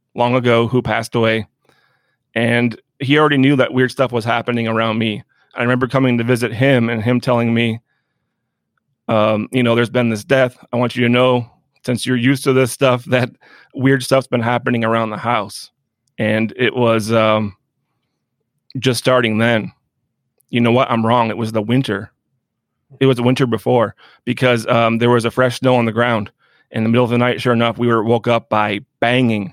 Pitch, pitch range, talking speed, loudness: 120 Hz, 115-130 Hz, 195 wpm, -16 LUFS